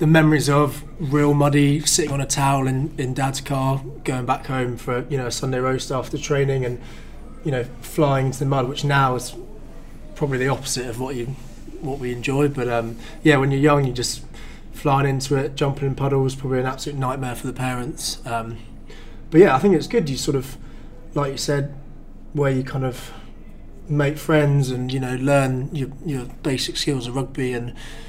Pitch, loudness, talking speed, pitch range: 135 Hz, -21 LUFS, 200 wpm, 130-145 Hz